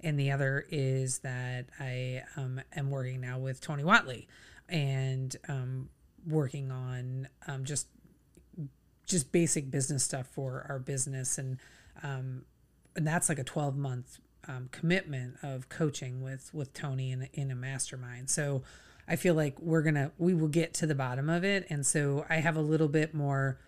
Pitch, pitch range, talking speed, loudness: 140 Hz, 130-155 Hz, 165 wpm, -33 LUFS